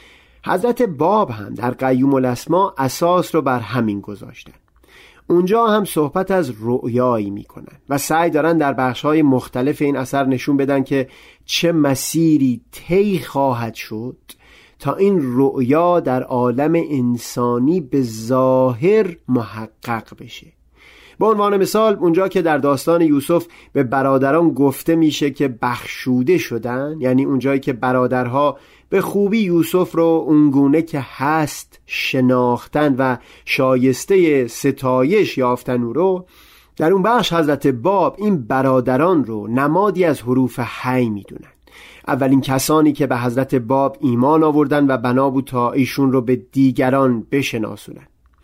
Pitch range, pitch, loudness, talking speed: 125-160 Hz, 135 Hz, -17 LUFS, 135 wpm